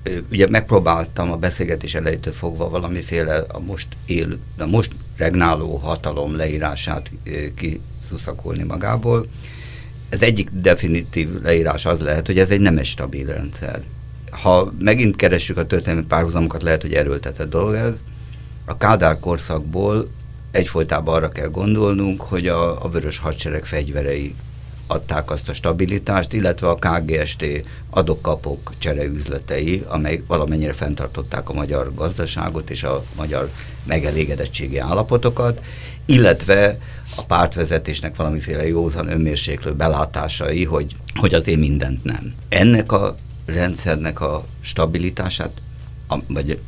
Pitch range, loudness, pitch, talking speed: 75-90 Hz, -20 LUFS, 80 Hz, 120 wpm